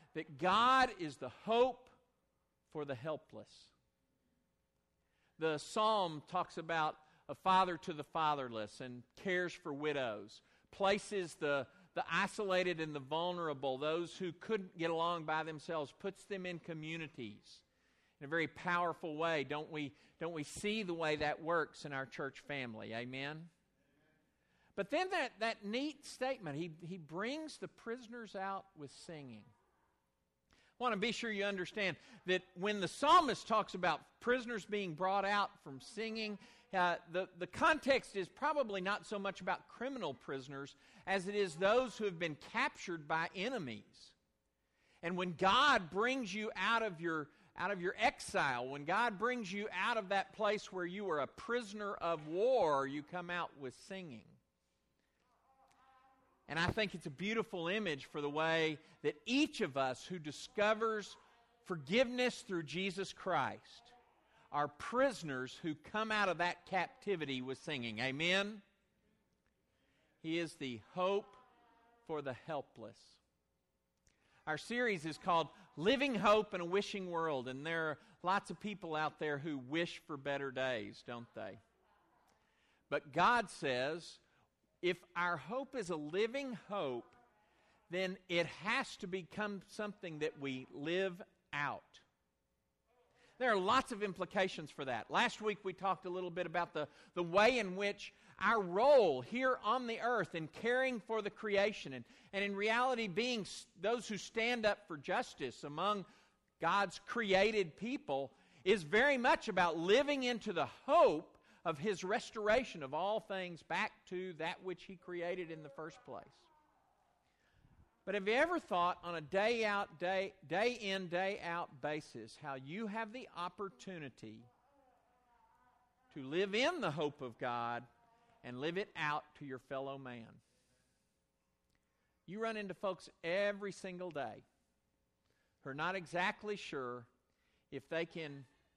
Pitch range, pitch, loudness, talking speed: 150-215 Hz, 180 Hz, -38 LUFS, 150 wpm